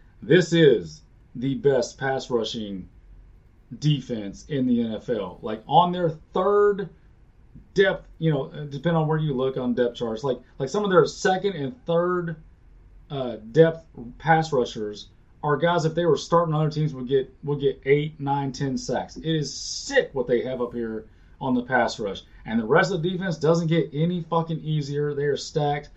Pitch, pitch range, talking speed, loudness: 145 Hz, 120-165 Hz, 185 wpm, -24 LUFS